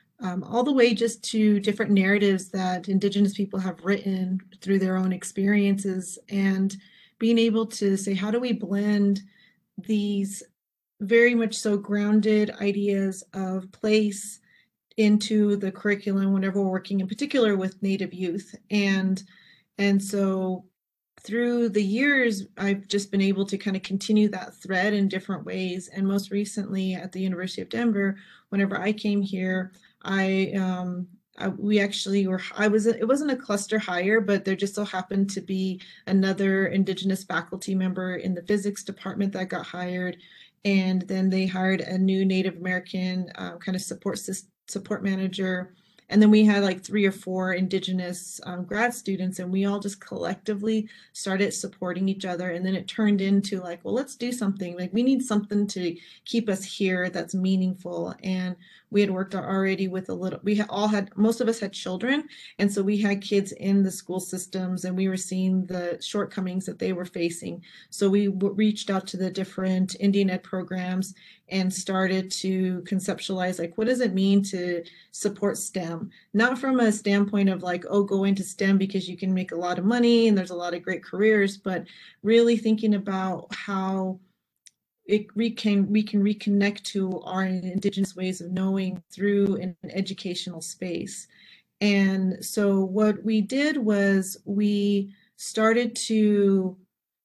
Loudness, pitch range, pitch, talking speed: -25 LUFS, 185-205 Hz, 195 Hz, 170 wpm